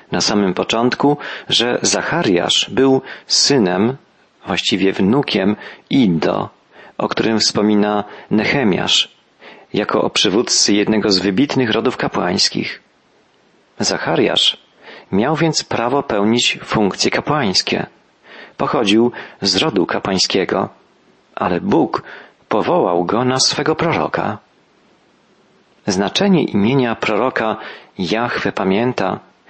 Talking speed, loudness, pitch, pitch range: 90 wpm, -16 LUFS, 110 Hz, 100-130 Hz